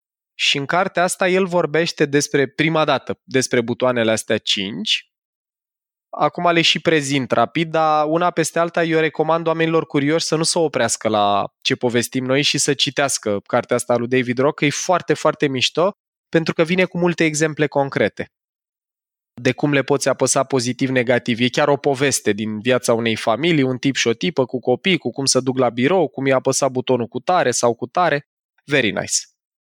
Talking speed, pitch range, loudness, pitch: 185 wpm, 125-160 Hz, -18 LUFS, 140 Hz